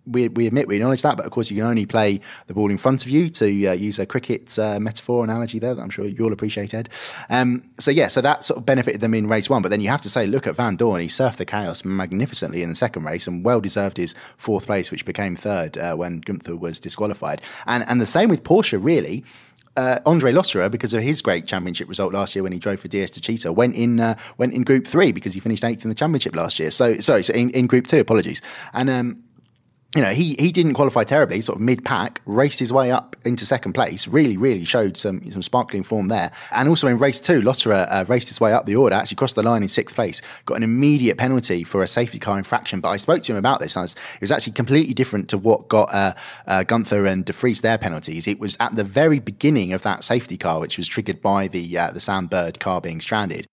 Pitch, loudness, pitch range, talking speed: 115 Hz, -20 LUFS, 100-125 Hz, 255 wpm